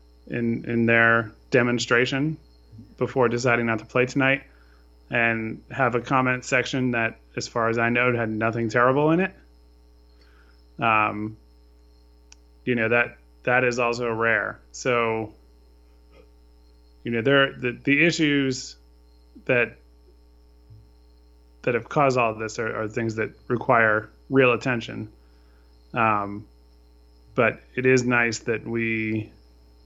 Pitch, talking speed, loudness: 110 Hz, 125 wpm, -23 LUFS